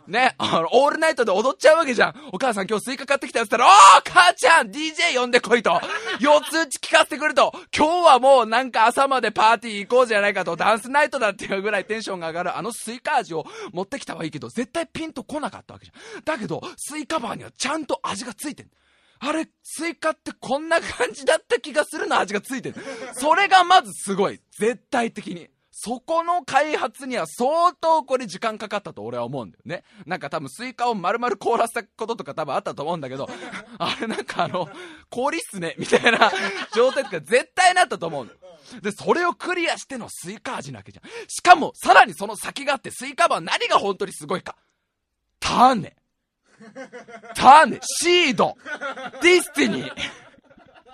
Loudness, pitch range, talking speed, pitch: -20 LUFS, 215-320 Hz, 405 characters per minute, 260 Hz